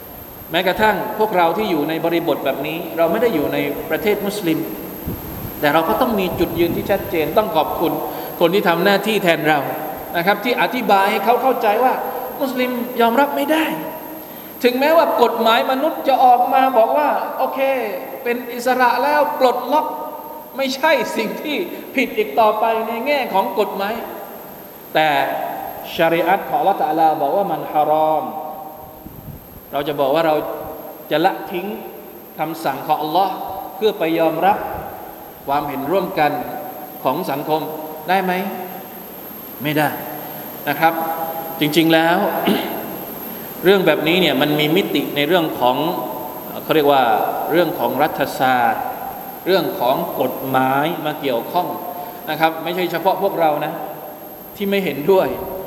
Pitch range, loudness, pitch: 155-225 Hz, -18 LUFS, 180 Hz